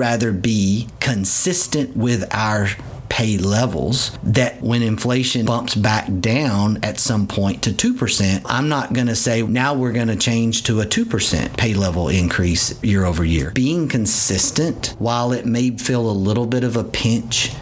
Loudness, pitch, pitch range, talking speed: -18 LUFS, 115 Hz, 105-125 Hz, 160 wpm